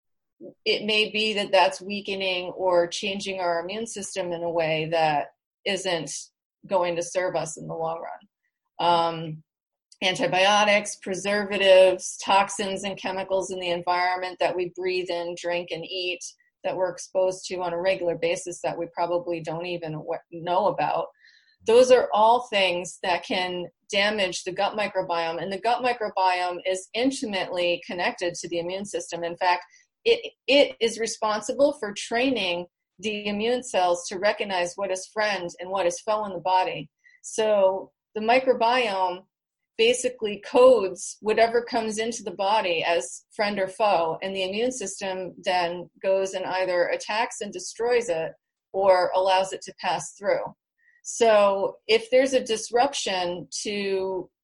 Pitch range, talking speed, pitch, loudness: 175-220 Hz, 150 wpm, 190 Hz, -25 LUFS